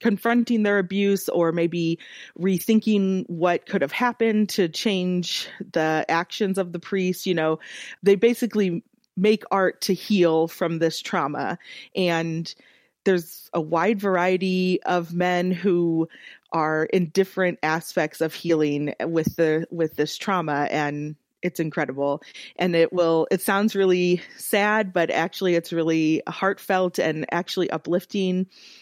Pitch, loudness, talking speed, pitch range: 180 Hz, -23 LUFS, 135 wpm, 165-195 Hz